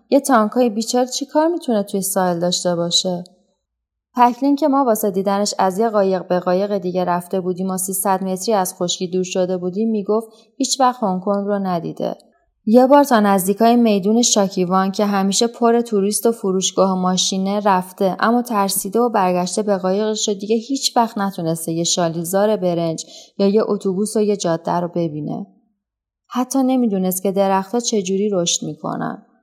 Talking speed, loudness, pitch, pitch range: 165 wpm, -18 LUFS, 200 Hz, 185-230 Hz